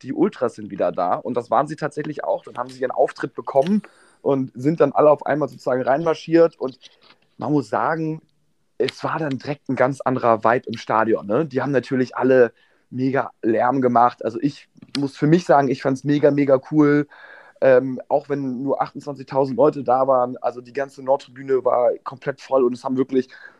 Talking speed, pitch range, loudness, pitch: 200 wpm, 125-145 Hz, -20 LUFS, 135 Hz